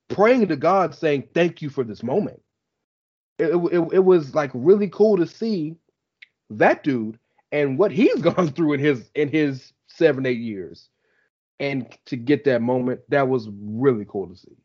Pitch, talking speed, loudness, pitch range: 145 Hz, 175 wpm, -21 LUFS, 130-170 Hz